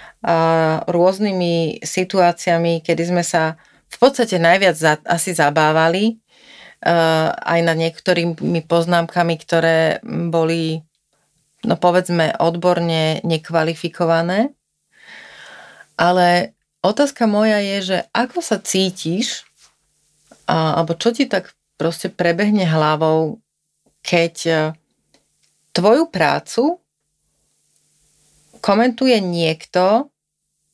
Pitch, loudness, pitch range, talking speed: 170 Hz, -17 LUFS, 160-190 Hz, 80 wpm